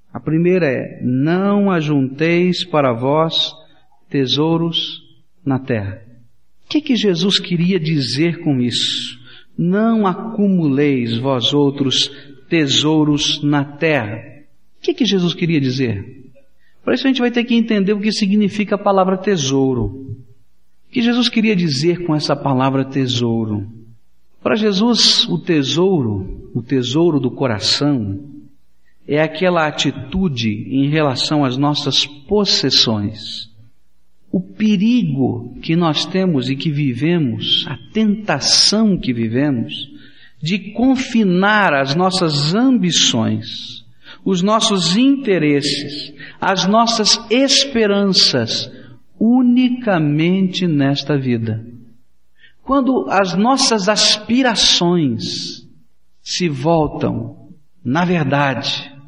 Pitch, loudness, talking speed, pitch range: 155 Hz, -16 LUFS, 105 wpm, 130-195 Hz